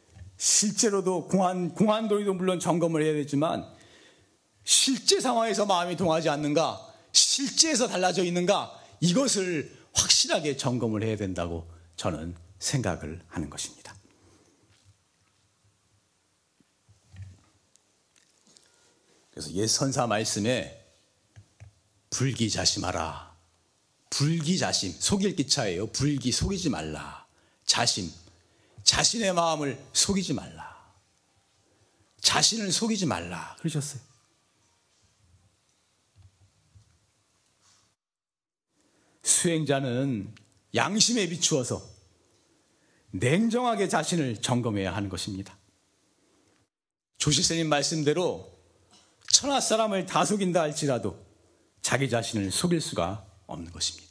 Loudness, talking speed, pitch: -26 LUFS, 215 characters per minute, 115 Hz